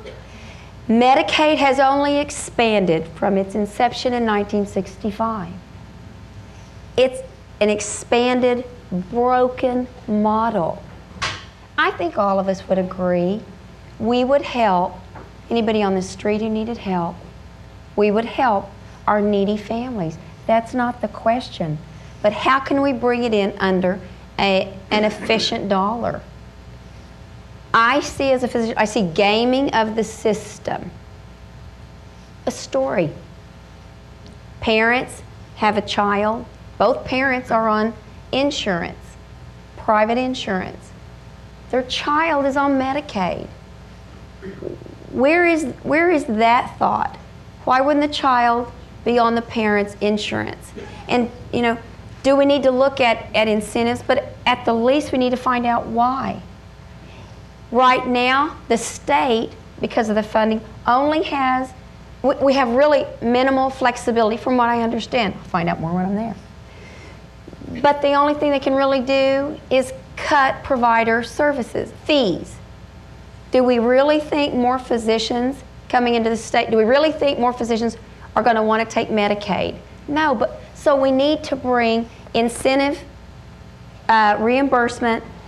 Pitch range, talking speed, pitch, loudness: 215-265 Hz, 135 wpm, 235 Hz, -19 LUFS